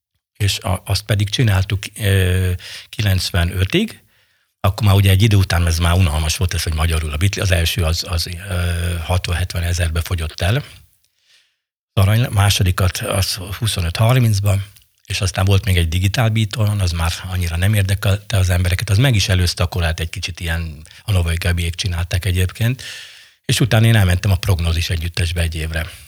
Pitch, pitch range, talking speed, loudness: 95 Hz, 85-100 Hz, 155 wpm, -18 LUFS